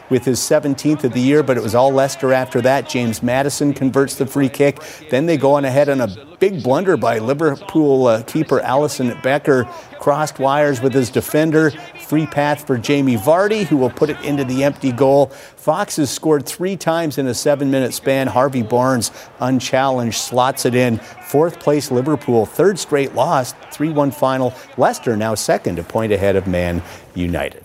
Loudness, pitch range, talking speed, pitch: -17 LUFS, 125-150 Hz, 180 wpm, 135 Hz